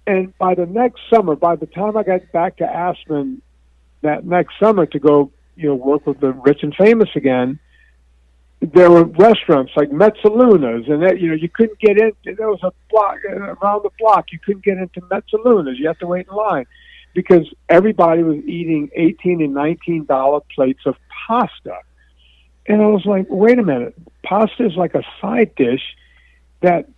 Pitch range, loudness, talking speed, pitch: 150-210 Hz, -15 LUFS, 185 wpm, 175 Hz